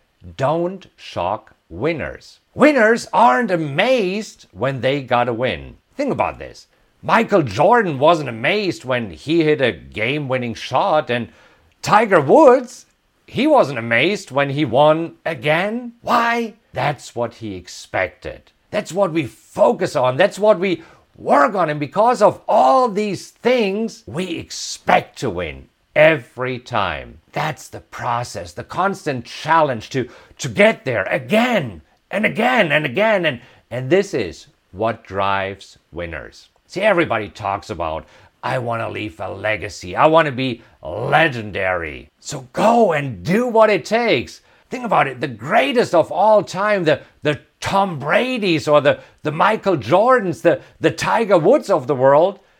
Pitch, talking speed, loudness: 150 Hz, 150 wpm, -18 LUFS